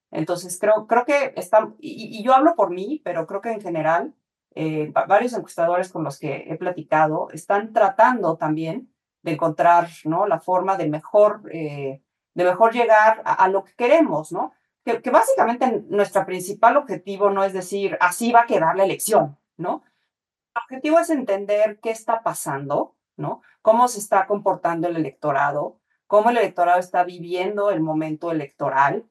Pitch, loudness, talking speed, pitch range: 195 Hz, -20 LUFS, 170 wpm, 170-225 Hz